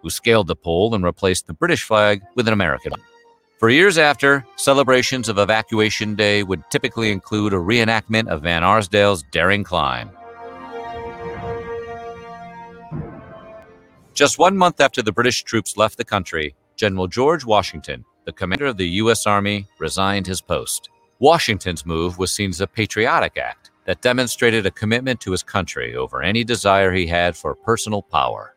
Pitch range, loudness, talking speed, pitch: 95-130 Hz, -18 LUFS, 160 wpm, 110 Hz